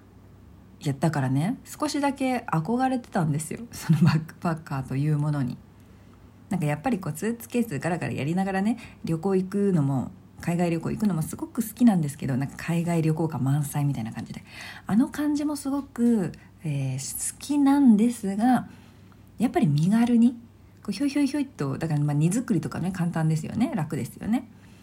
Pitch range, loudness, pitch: 140-235 Hz, -26 LUFS, 170 Hz